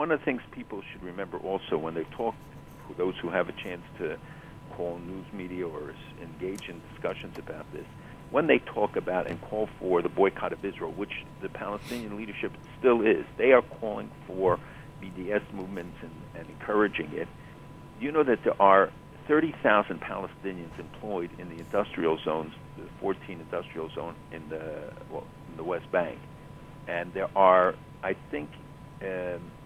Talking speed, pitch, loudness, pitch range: 165 wpm, 95 Hz, -29 LUFS, 90-120 Hz